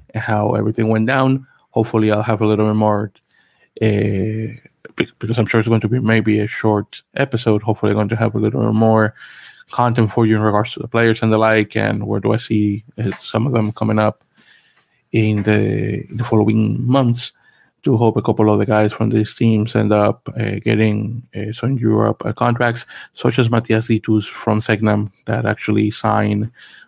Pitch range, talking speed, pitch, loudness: 105-115 Hz, 190 wpm, 110 Hz, -17 LUFS